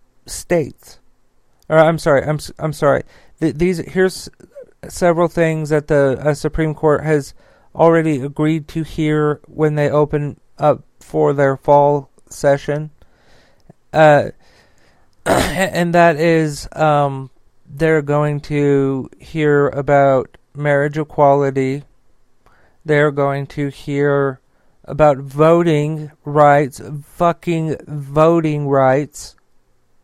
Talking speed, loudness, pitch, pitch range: 105 wpm, -16 LUFS, 150 Hz, 140-155 Hz